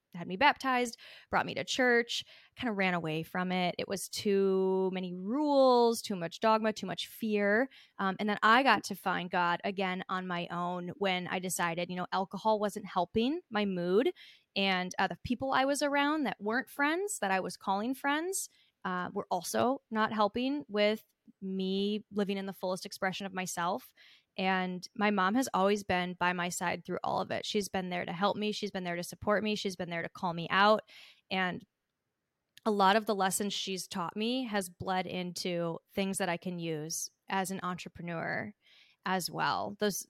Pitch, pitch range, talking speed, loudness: 195 Hz, 180-220 Hz, 195 wpm, -32 LUFS